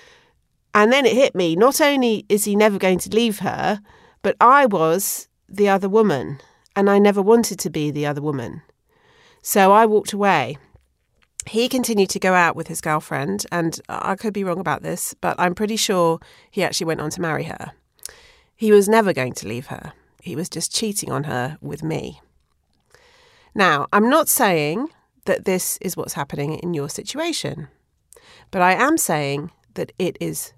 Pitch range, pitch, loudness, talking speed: 165-230 Hz, 200 Hz, -19 LUFS, 180 wpm